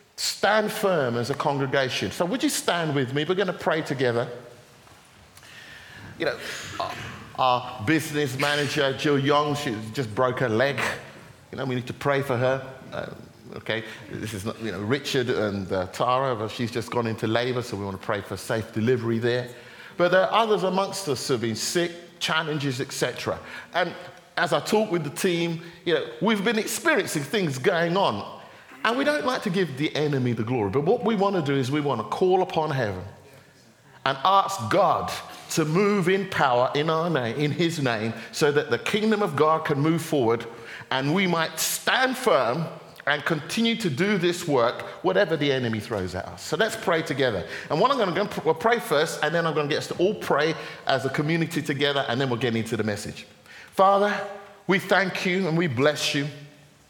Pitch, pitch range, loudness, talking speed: 150 Hz, 120-180 Hz, -24 LUFS, 205 wpm